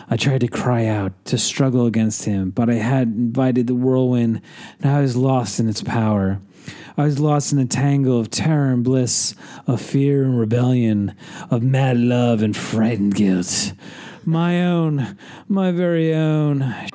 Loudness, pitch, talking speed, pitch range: -19 LUFS, 125 Hz, 165 wpm, 110-140 Hz